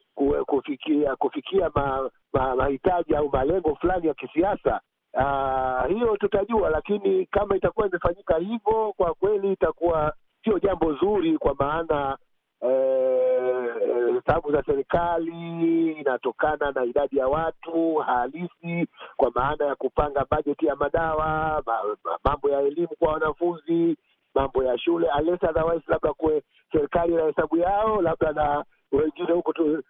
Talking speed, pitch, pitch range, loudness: 135 wpm, 160 Hz, 145-185 Hz, -24 LUFS